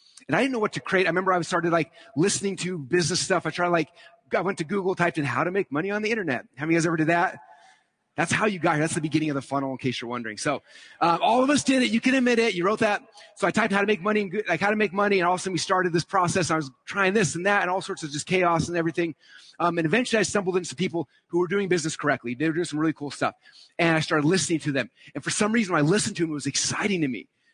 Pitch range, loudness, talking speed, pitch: 160-200 Hz, -24 LUFS, 310 wpm, 175 Hz